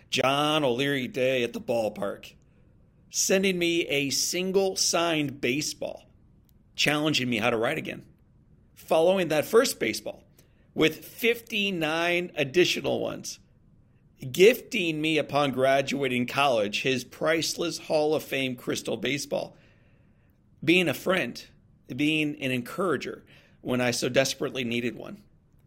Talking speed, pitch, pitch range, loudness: 115 wpm, 150 Hz, 135-170 Hz, -26 LUFS